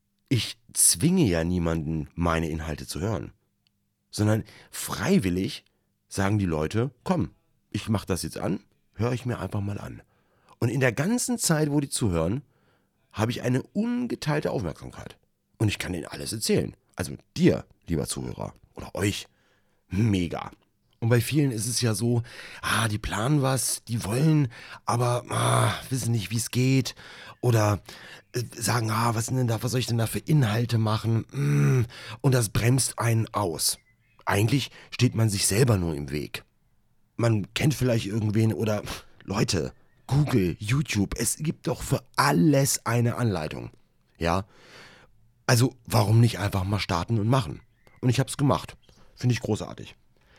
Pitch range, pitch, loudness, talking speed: 100-125 Hz, 115 Hz, -26 LUFS, 155 wpm